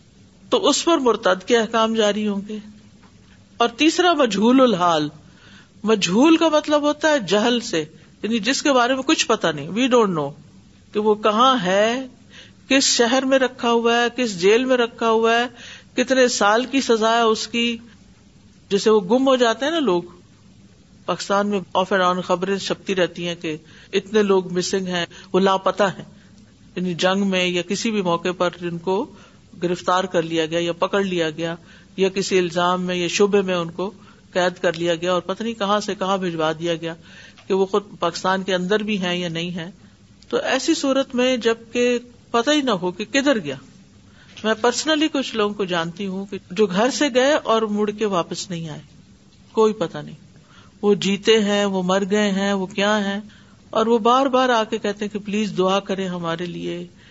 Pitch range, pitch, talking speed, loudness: 180-235 Hz, 205 Hz, 195 wpm, -20 LUFS